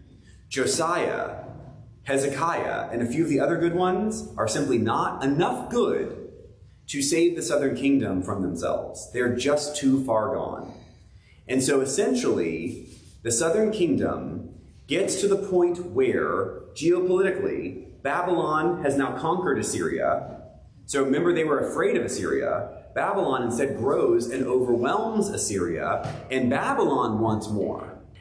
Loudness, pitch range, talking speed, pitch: -25 LUFS, 120-185 Hz, 130 wpm, 145 Hz